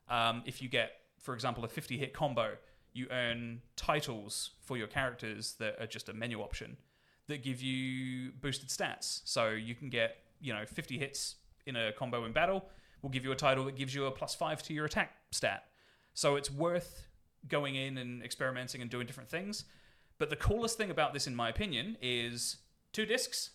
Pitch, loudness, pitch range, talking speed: 130 Hz, -37 LUFS, 120-140 Hz, 200 wpm